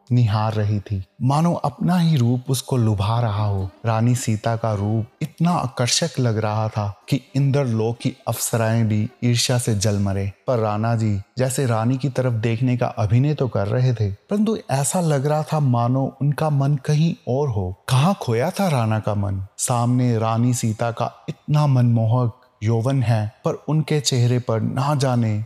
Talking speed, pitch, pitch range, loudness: 170 wpm, 120 Hz, 110-140 Hz, -21 LUFS